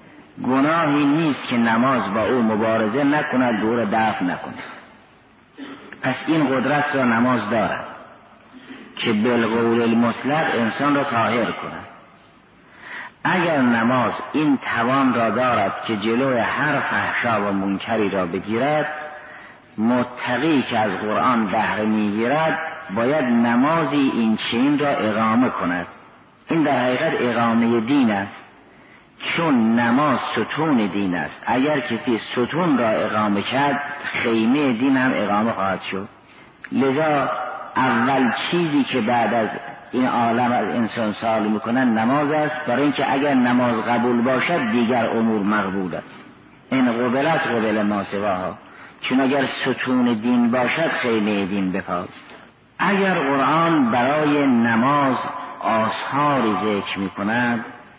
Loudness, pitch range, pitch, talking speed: -20 LUFS, 110-140 Hz, 120 Hz, 120 wpm